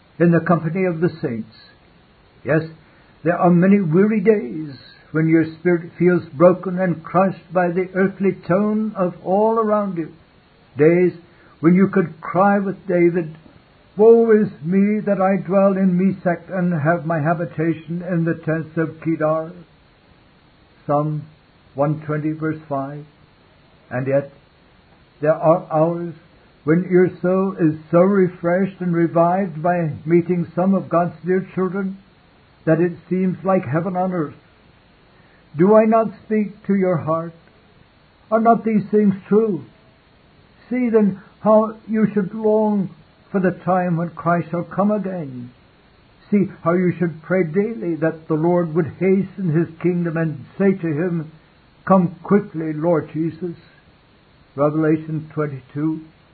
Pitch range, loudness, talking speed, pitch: 160-190 Hz, -19 LUFS, 140 wpm, 175 Hz